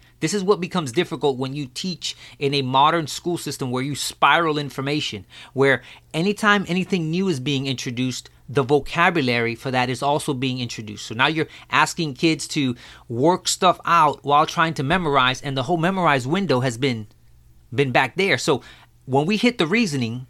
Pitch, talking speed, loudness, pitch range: 140 Hz, 180 wpm, -21 LUFS, 130-170 Hz